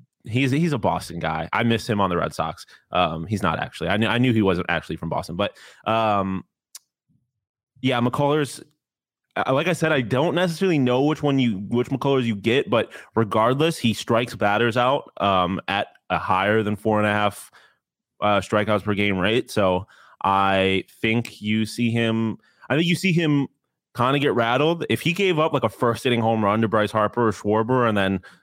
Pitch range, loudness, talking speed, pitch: 105-135 Hz, -22 LUFS, 200 wpm, 115 Hz